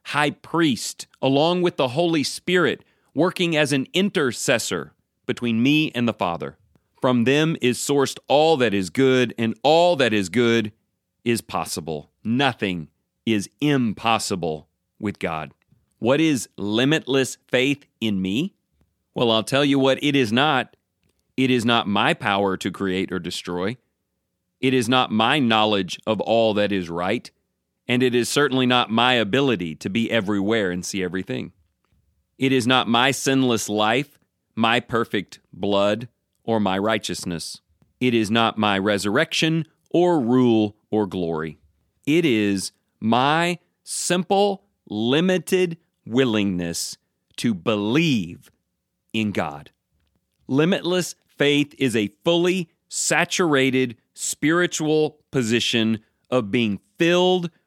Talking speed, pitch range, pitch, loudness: 130 wpm, 100-140 Hz, 115 Hz, -21 LUFS